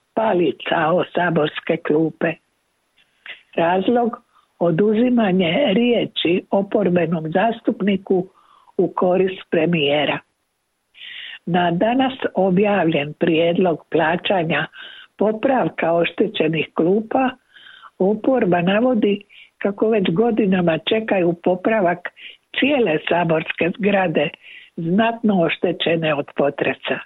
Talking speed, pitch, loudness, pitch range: 75 wpm, 190 Hz, -19 LUFS, 170-225 Hz